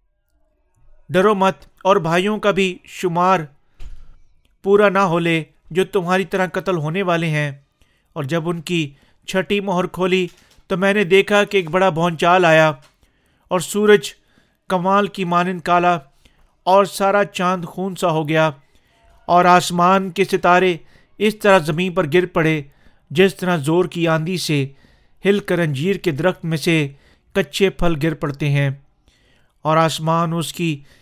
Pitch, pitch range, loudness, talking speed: 175 Hz, 155-190 Hz, -18 LUFS, 155 wpm